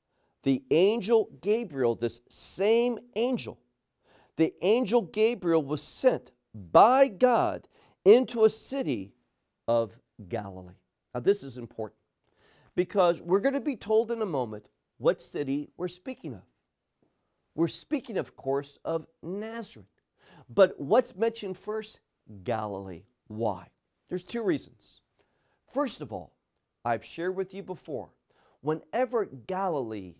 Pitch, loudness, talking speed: 175 Hz, -28 LUFS, 120 wpm